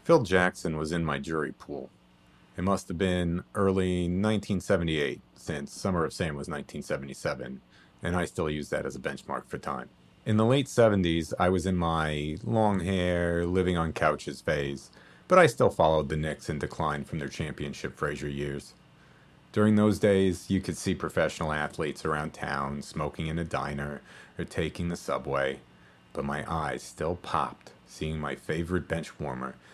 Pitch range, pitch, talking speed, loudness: 70-95 Hz, 80 Hz, 170 wpm, -29 LUFS